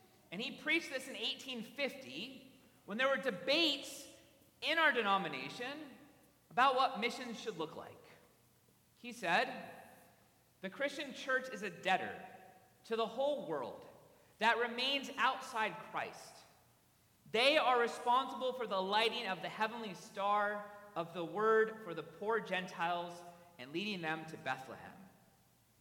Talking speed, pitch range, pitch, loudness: 135 wpm, 185-260 Hz, 225 Hz, -36 LUFS